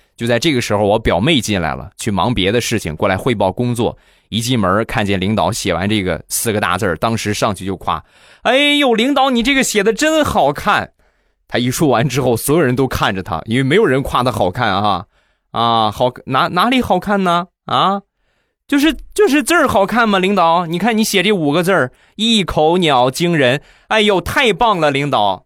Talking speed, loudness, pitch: 285 characters per minute, -15 LUFS, 140 Hz